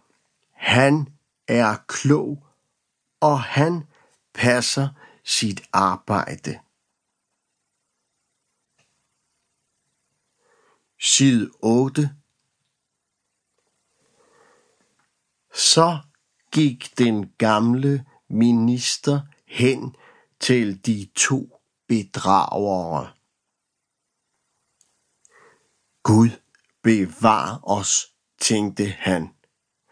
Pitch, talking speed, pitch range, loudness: 125 Hz, 50 wpm, 110-140 Hz, -20 LUFS